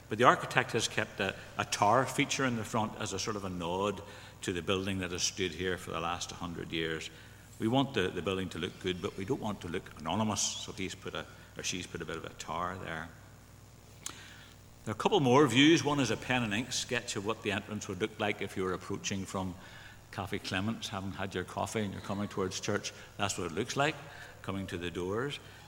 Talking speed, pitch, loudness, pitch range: 245 wpm, 105 Hz, -33 LUFS, 95-115 Hz